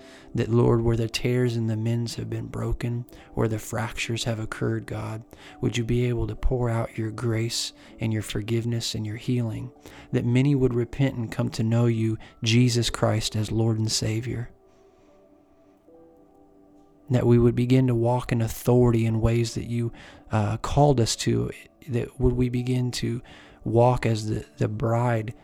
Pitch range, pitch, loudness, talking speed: 110-125 Hz, 115 Hz, -25 LUFS, 170 wpm